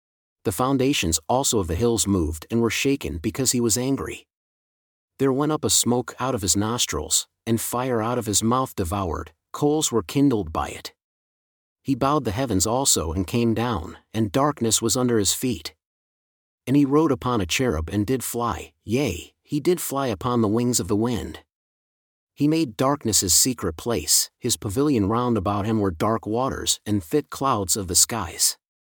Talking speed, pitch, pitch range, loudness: 180 wpm, 115 Hz, 100-130 Hz, -22 LUFS